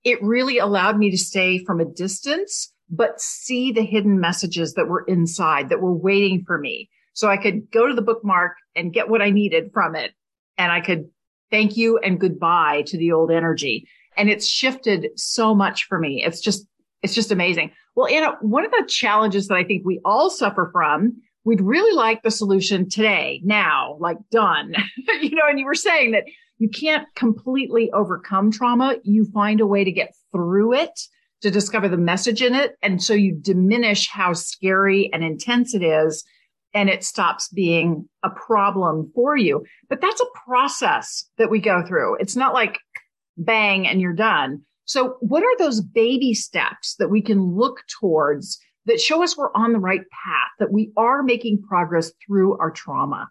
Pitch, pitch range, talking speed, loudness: 210 Hz, 185-235 Hz, 190 wpm, -19 LUFS